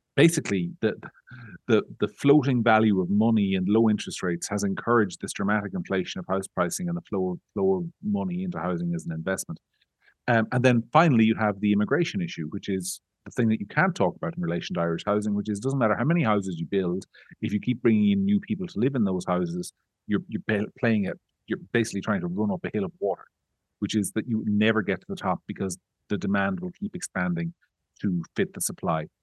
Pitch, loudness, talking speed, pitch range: 105 Hz, -26 LUFS, 225 wpm, 95-130 Hz